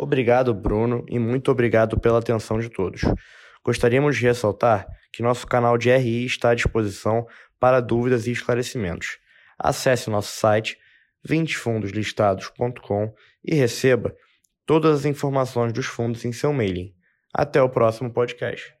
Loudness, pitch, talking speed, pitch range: -22 LUFS, 120 Hz, 135 wpm, 110-130 Hz